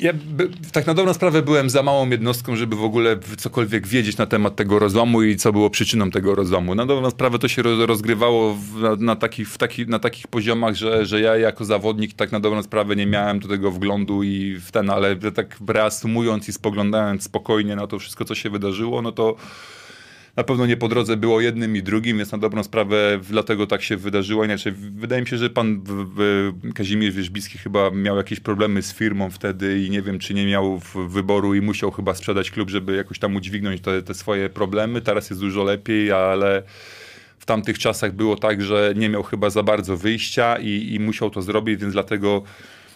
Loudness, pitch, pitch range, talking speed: -21 LUFS, 105 Hz, 100-115 Hz, 205 wpm